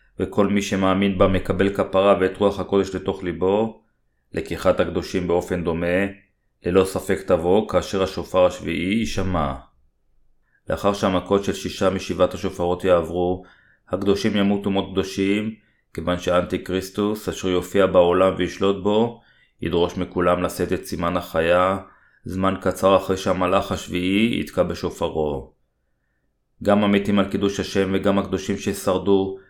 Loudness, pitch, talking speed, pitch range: -21 LUFS, 95 Hz, 125 wpm, 90-100 Hz